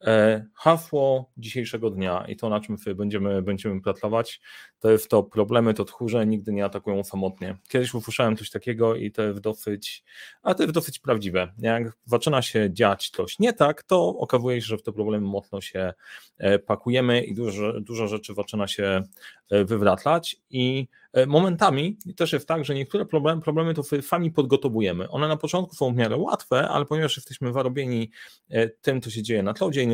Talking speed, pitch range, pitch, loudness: 175 wpm, 105-140 Hz, 115 Hz, -24 LUFS